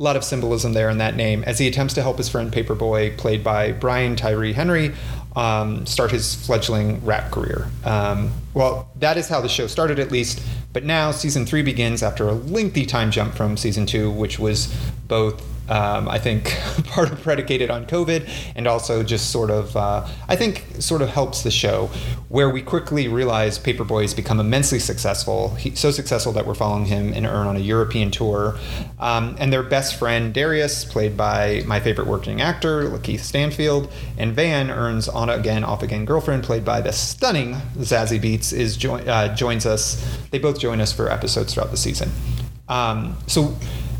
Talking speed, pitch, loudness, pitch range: 190 wpm, 115 Hz, -21 LUFS, 110-135 Hz